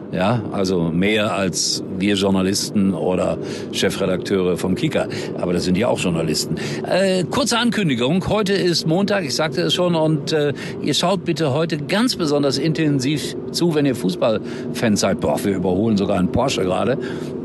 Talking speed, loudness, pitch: 160 wpm, -19 LUFS, 135 Hz